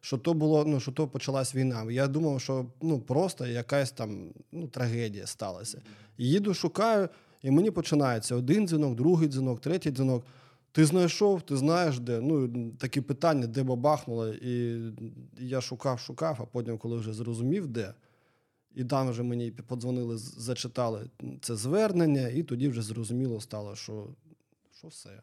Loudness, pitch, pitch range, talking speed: -30 LUFS, 130 Hz, 120-155 Hz, 155 wpm